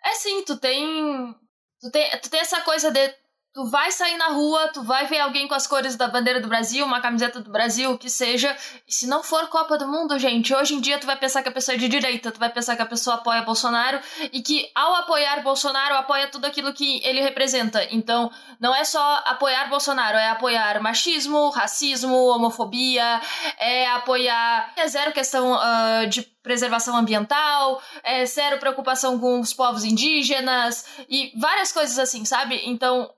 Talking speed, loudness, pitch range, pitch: 190 wpm, -21 LUFS, 245-285 Hz, 265 Hz